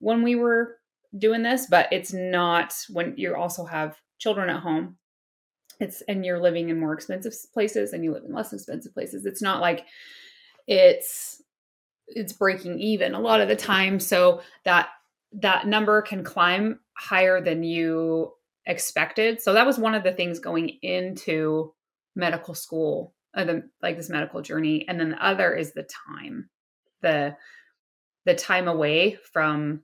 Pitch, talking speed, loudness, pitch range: 185 Hz, 160 wpm, -24 LUFS, 170-220 Hz